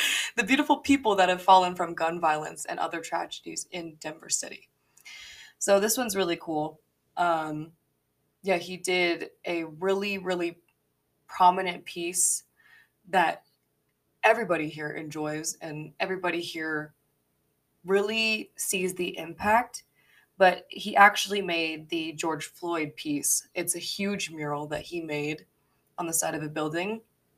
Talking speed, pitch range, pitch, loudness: 135 wpm, 155-195 Hz, 175 Hz, -27 LUFS